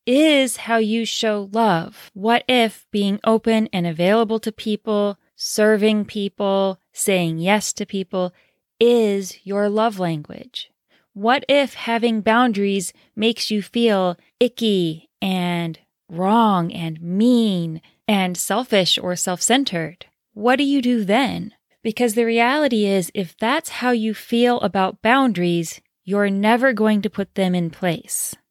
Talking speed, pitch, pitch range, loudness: 135 wpm, 210 Hz, 190-230 Hz, -19 LUFS